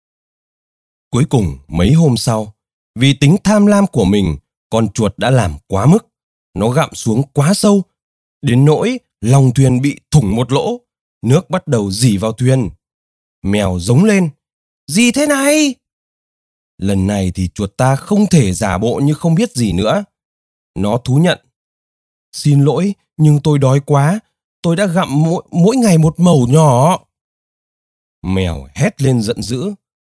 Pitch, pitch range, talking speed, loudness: 135 Hz, 100-170 Hz, 155 wpm, -14 LUFS